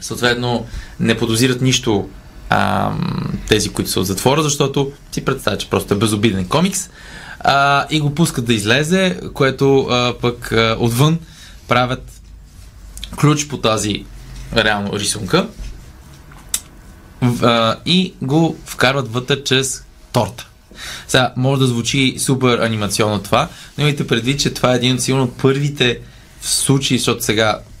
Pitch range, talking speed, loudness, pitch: 110-140 Hz, 135 wpm, -16 LUFS, 125 Hz